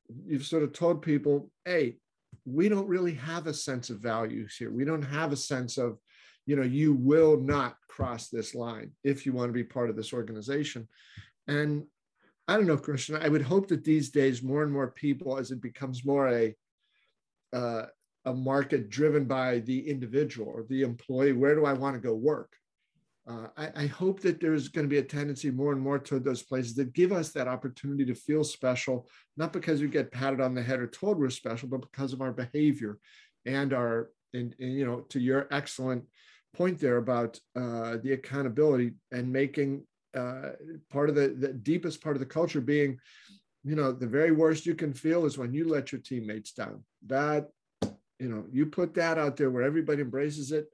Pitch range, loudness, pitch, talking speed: 125-150 Hz, -30 LUFS, 140 Hz, 205 wpm